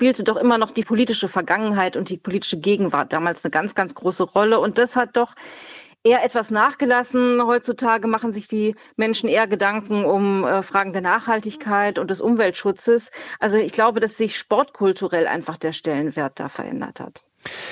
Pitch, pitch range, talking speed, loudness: 215 Hz, 190-230 Hz, 170 wpm, -20 LUFS